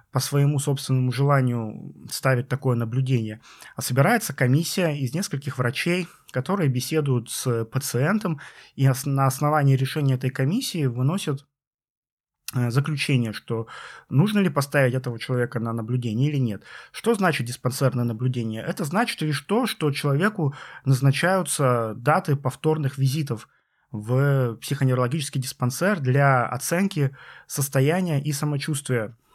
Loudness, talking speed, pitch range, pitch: -24 LUFS, 115 wpm, 125-150 Hz, 135 Hz